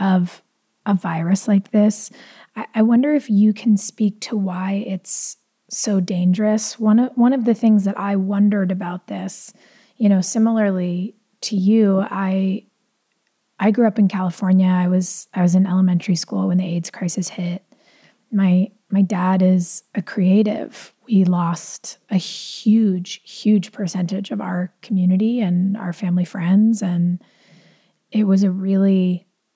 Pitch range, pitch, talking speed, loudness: 185-215 Hz, 195 Hz, 150 wpm, -19 LUFS